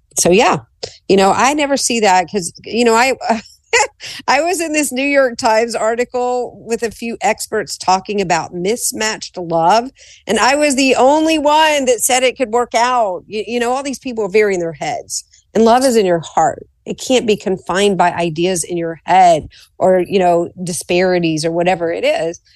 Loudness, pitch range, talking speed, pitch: -15 LUFS, 185-255 Hz, 195 wpm, 220 Hz